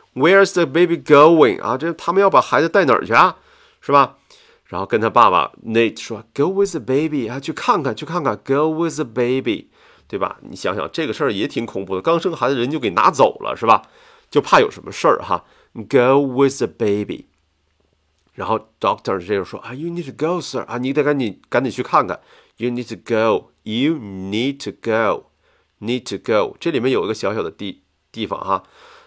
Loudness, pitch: -18 LUFS, 145 Hz